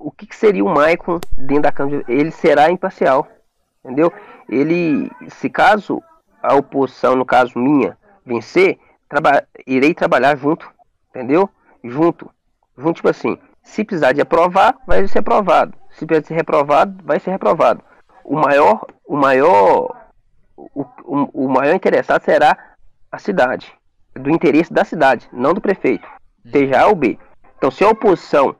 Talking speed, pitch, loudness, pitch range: 150 wpm, 165 Hz, -15 LUFS, 145-210 Hz